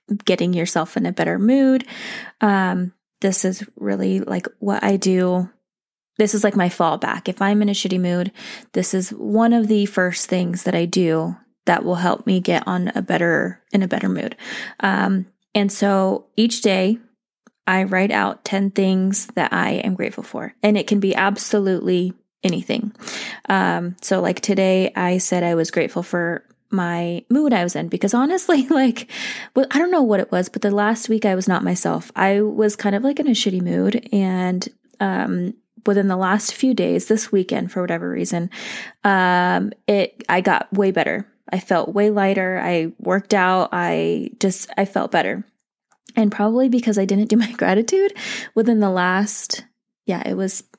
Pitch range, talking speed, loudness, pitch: 185-220 Hz, 180 wpm, -19 LUFS, 200 Hz